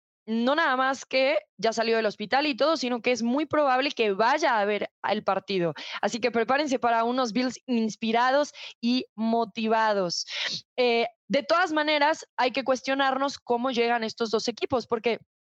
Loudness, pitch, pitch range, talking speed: -26 LUFS, 245 Hz, 225-270 Hz, 165 wpm